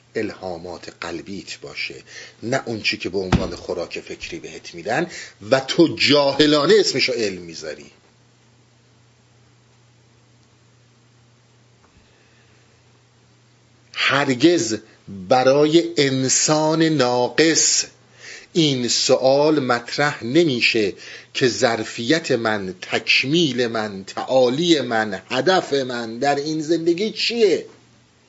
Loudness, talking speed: -19 LUFS, 85 wpm